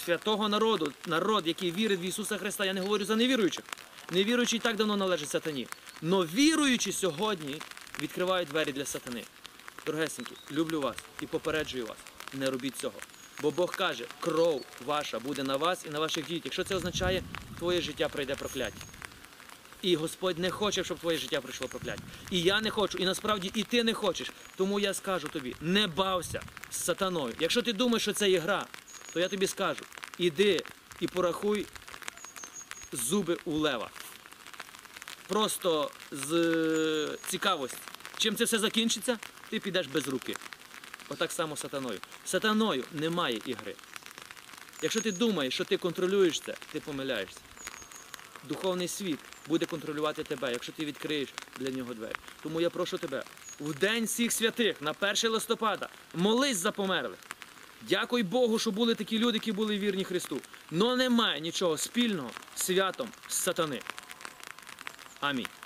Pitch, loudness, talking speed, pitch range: 185 Hz, -31 LUFS, 150 wpm, 155-215 Hz